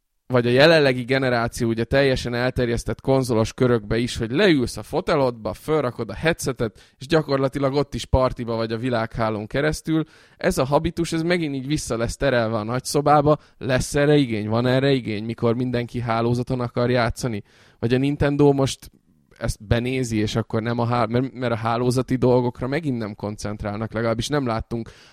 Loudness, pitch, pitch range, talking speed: -22 LUFS, 125 Hz, 115-135 Hz, 160 wpm